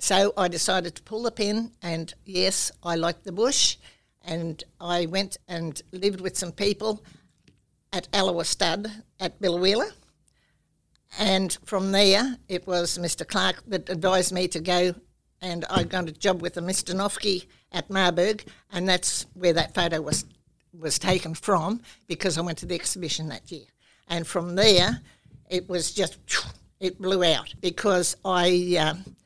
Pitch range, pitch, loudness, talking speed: 170-195 Hz, 180 Hz, -25 LUFS, 160 wpm